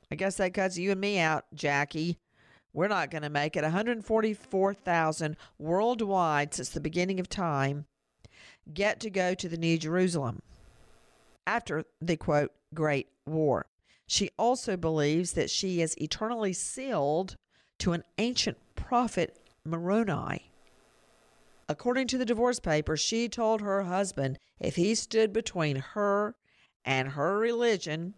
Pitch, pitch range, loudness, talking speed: 180 Hz, 155-205 Hz, -30 LUFS, 135 wpm